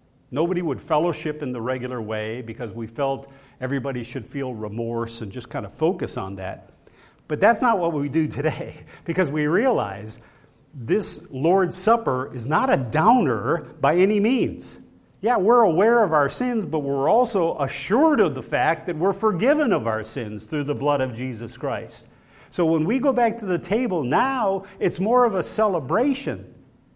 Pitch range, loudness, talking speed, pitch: 125-190 Hz, -23 LUFS, 180 wpm, 145 Hz